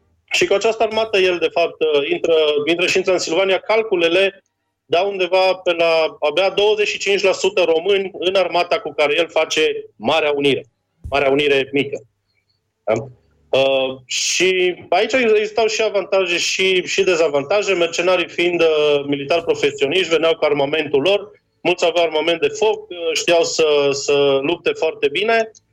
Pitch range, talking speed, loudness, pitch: 150-215 Hz, 140 wpm, -17 LUFS, 175 Hz